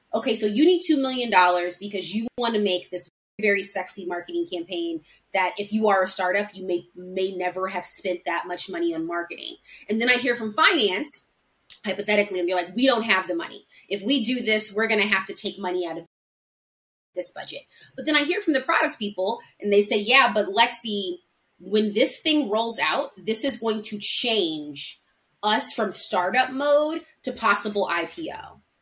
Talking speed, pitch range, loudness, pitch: 195 wpm, 180-235 Hz, -23 LUFS, 205 Hz